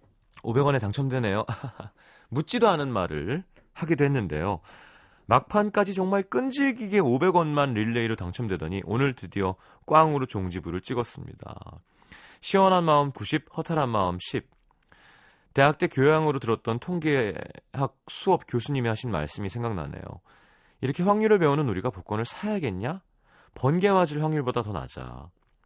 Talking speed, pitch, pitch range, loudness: 300 characters per minute, 130 Hz, 105-155 Hz, -26 LUFS